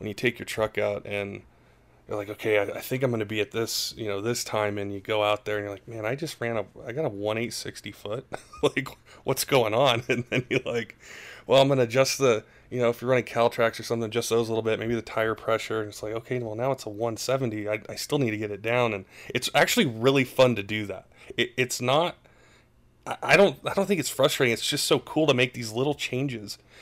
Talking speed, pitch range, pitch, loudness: 255 wpm, 105-130 Hz, 115 Hz, -26 LUFS